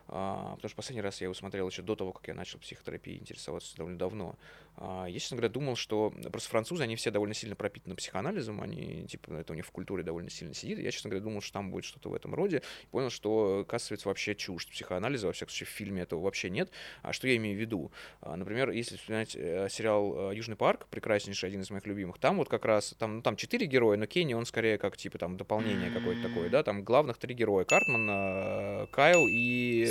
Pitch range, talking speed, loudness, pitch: 95-115 Hz, 230 wpm, -33 LUFS, 105 Hz